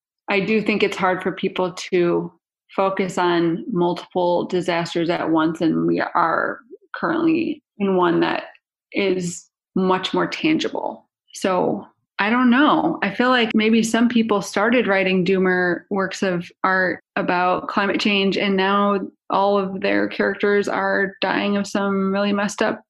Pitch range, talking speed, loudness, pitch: 180-210 Hz, 150 wpm, -20 LUFS, 195 Hz